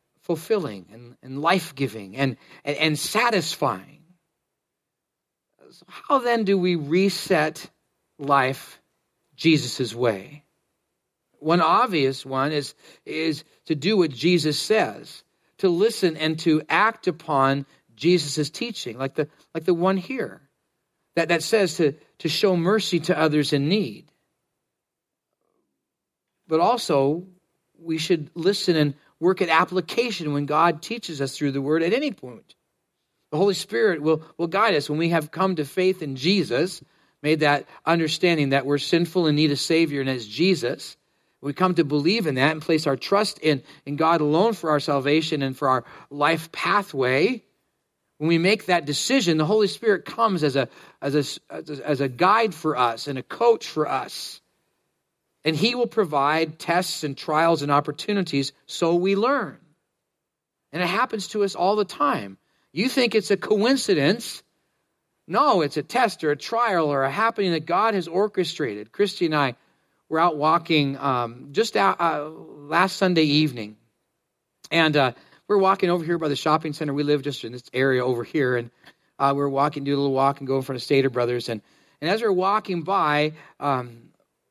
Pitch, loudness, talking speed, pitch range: 160 Hz, -23 LUFS, 170 wpm, 140-185 Hz